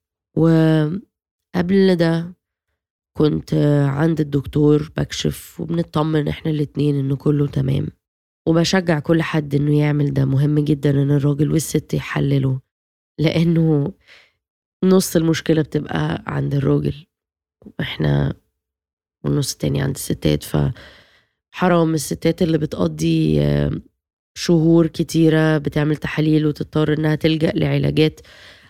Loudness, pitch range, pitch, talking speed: -19 LUFS, 140-160 Hz, 150 Hz, 100 wpm